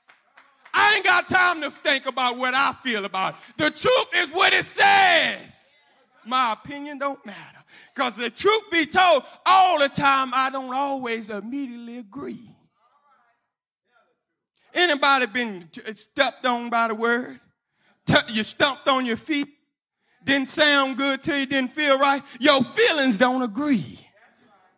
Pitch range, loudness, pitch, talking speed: 245-305 Hz, -20 LUFS, 275 Hz, 150 wpm